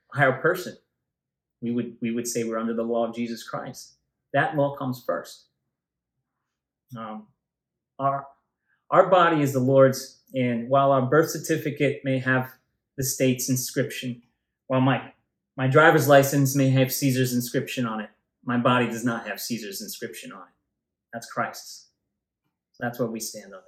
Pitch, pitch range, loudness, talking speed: 130 Hz, 120-140 Hz, -24 LUFS, 160 wpm